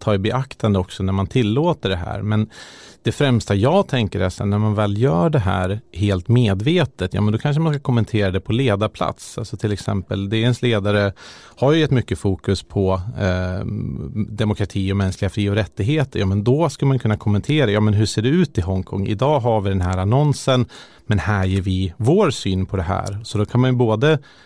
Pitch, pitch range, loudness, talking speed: 105 Hz, 100-125 Hz, -20 LUFS, 215 wpm